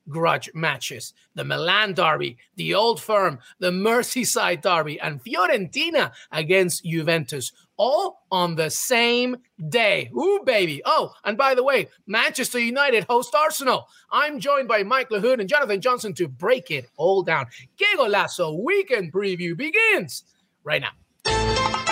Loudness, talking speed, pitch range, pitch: -22 LUFS, 140 wpm, 170-275 Hz, 225 Hz